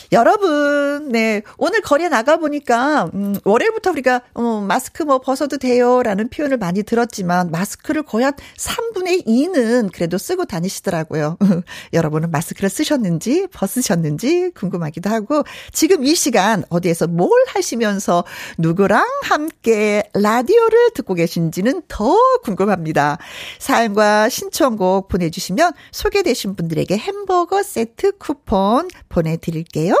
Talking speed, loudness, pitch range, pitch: 315 characters per minute, -17 LUFS, 190-305 Hz, 230 Hz